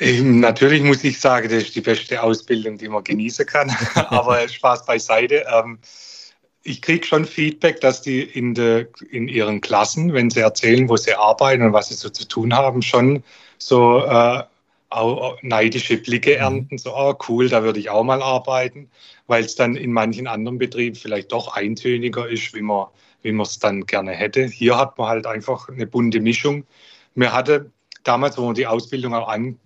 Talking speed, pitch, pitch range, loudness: 185 wpm, 120 Hz, 115-130 Hz, -18 LUFS